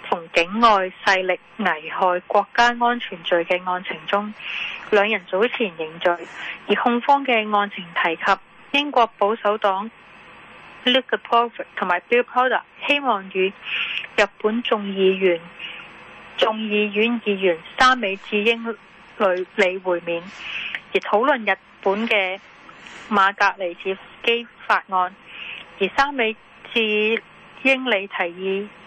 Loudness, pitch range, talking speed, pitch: -21 LUFS, 185-230 Hz, 205 characters per minute, 200 Hz